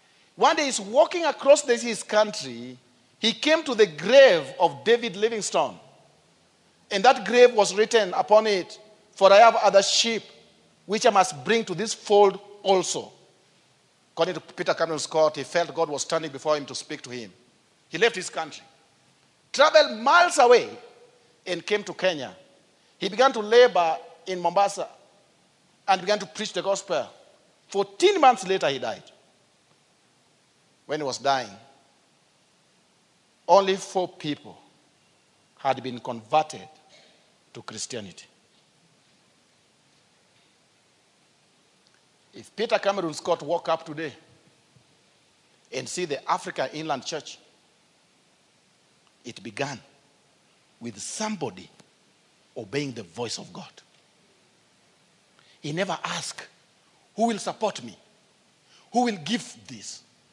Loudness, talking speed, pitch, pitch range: -23 LUFS, 125 wpm, 195 Hz, 155-220 Hz